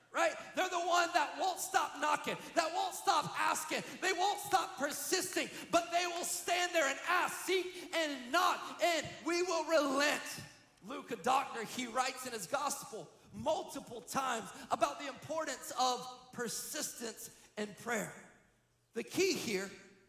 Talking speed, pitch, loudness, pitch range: 150 wpm, 315 Hz, -35 LUFS, 255-350 Hz